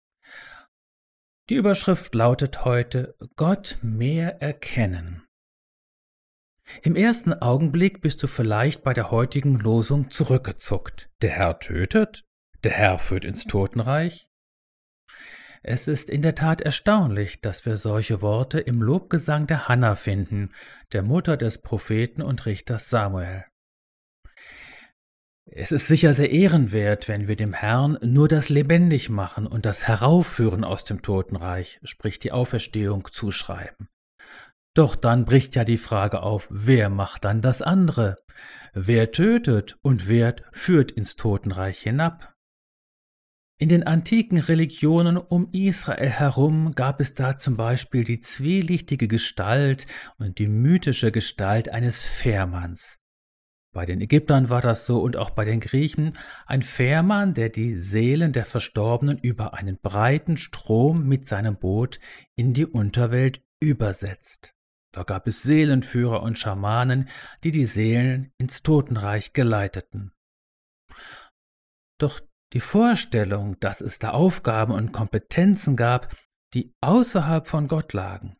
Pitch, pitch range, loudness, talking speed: 120 Hz, 105-150 Hz, -22 LUFS, 130 wpm